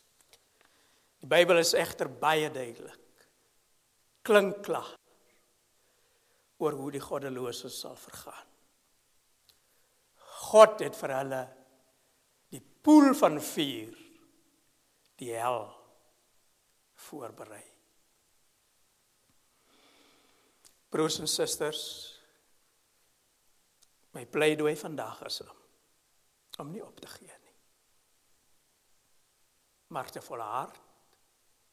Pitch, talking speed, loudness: 155 Hz, 75 wpm, -28 LUFS